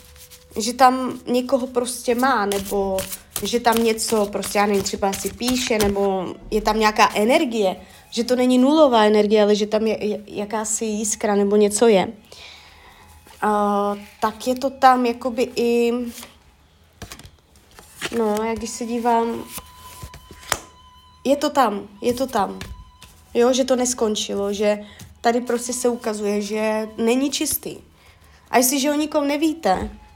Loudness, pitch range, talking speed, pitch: -20 LUFS, 205-250 Hz, 135 wpm, 220 Hz